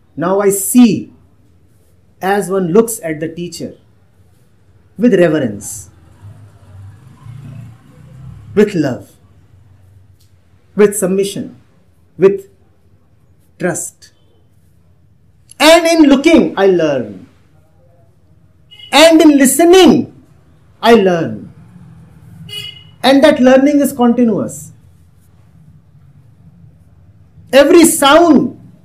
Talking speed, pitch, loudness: 70 wpm, 135 Hz, -10 LUFS